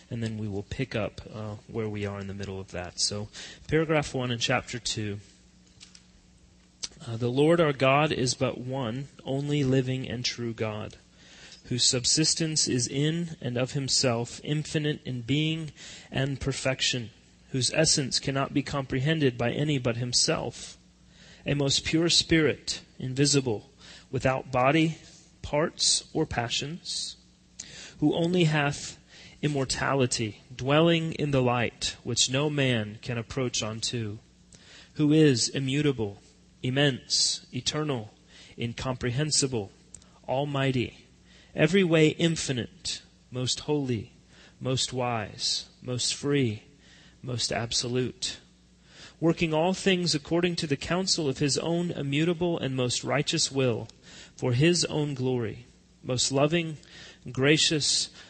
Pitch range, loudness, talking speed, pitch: 120-150 Hz, -27 LUFS, 120 wpm, 130 Hz